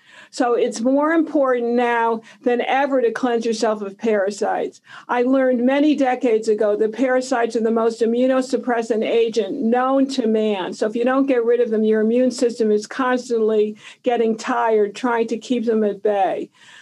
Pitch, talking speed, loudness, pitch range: 235 Hz, 170 wpm, -19 LUFS, 225-255 Hz